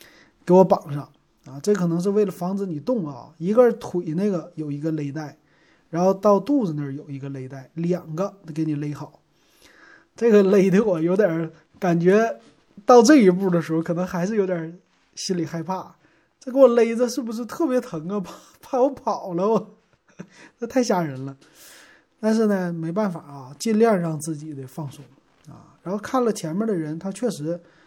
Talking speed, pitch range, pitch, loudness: 265 characters per minute, 160-215 Hz, 180 Hz, -22 LUFS